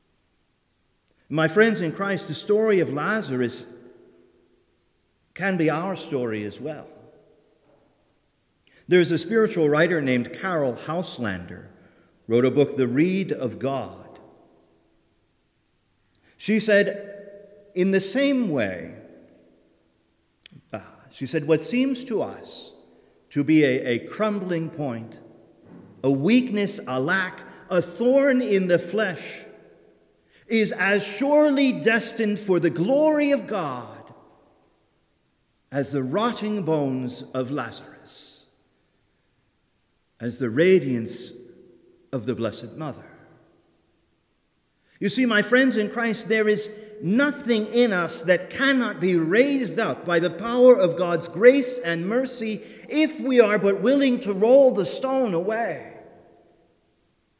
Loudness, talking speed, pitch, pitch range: -22 LUFS, 115 wpm, 185 Hz, 140-225 Hz